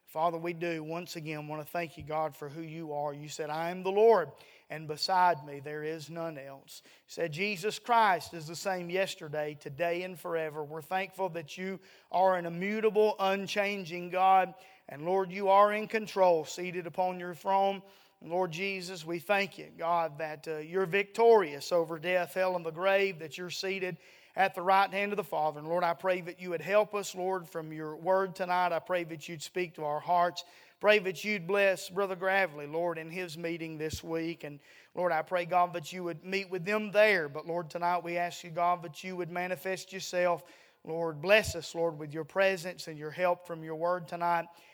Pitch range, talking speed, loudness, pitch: 165-190 Hz, 205 wpm, -31 LUFS, 175 Hz